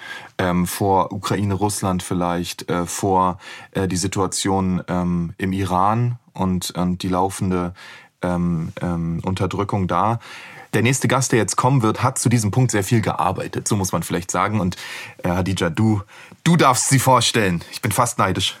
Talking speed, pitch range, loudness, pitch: 170 wpm, 90-115 Hz, -20 LUFS, 95 Hz